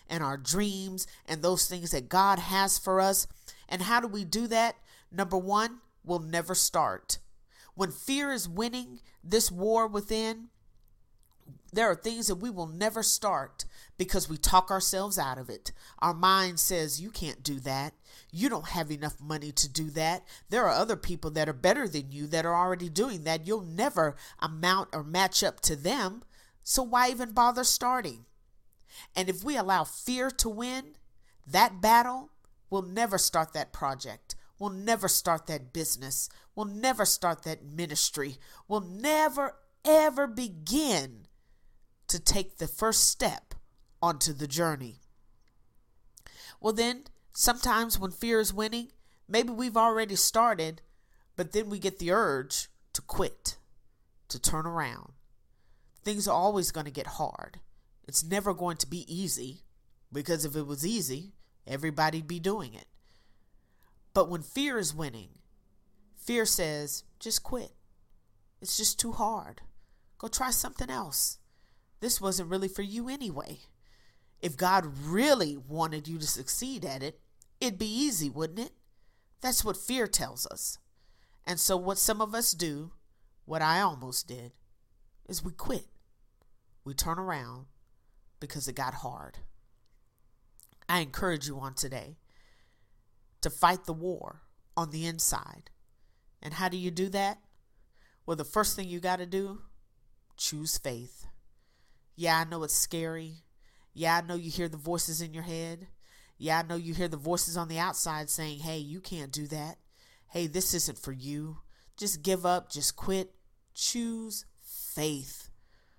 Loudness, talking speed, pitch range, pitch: -30 LUFS, 155 wpm, 145-205 Hz, 170 Hz